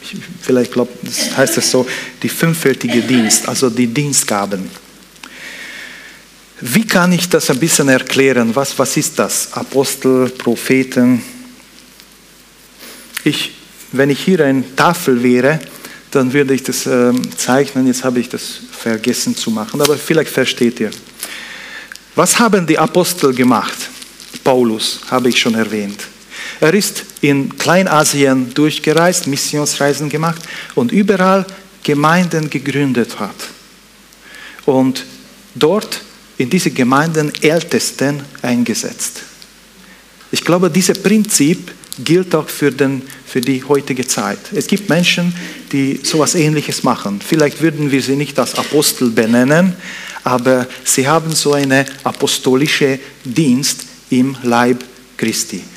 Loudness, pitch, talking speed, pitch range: -14 LUFS, 140 Hz, 125 wpm, 130-165 Hz